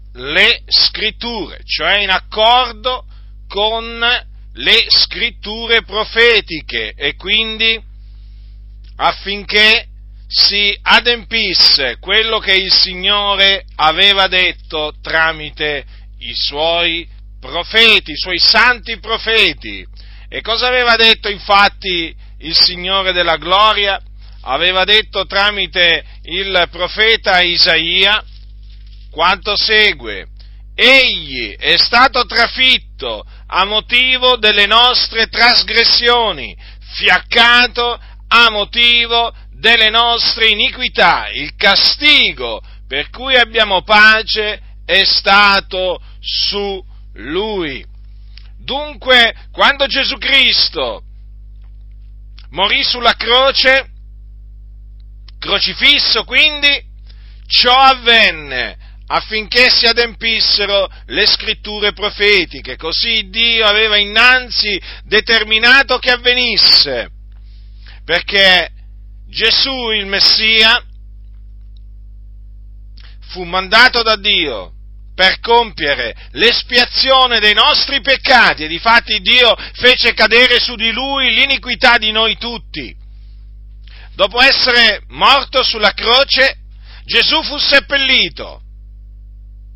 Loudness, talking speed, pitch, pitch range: -10 LUFS, 85 wpm, 205 Hz, 145-235 Hz